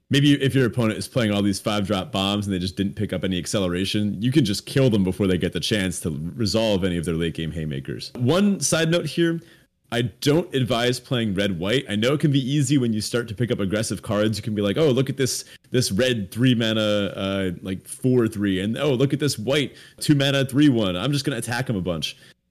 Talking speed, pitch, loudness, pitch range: 250 wpm, 110 Hz, -22 LUFS, 100-135 Hz